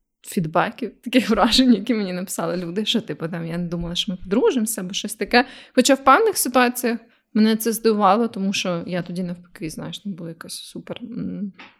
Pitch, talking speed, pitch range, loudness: 215 Hz, 185 wpm, 180-240 Hz, -20 LUFS